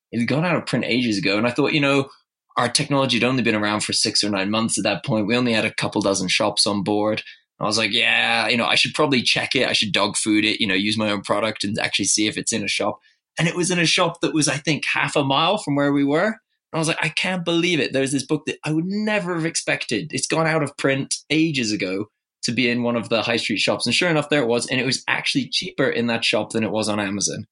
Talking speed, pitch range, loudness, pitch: 295 wpm, 110-160 Hz, -20 LUFS, 135 Hz